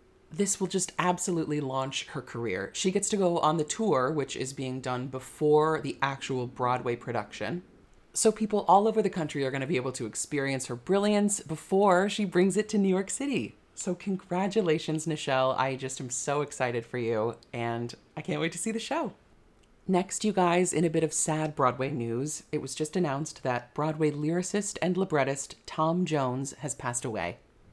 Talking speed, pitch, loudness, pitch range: 190 wpm, 155 Hz, -29 LUFS, 130-185 Hz